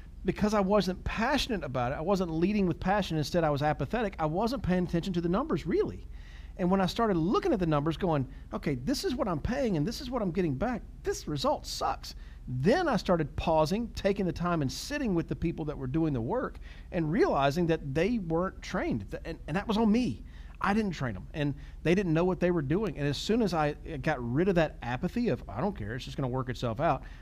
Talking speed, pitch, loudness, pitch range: 240 wpm, 170 Hz, -30 LUFS, 150-195 Hz